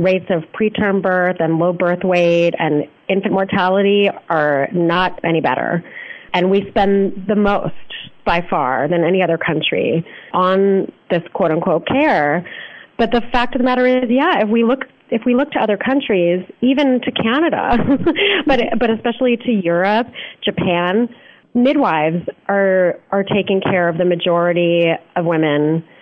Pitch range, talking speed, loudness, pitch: 175-235 Hz, 150 wpm, -16 LUFS, 195 Hz